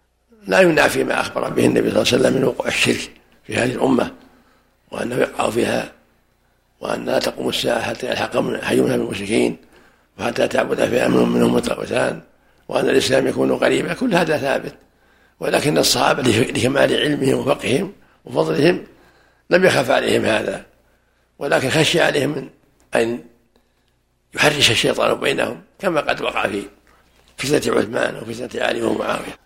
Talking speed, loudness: 135 wpm, -18 LUFS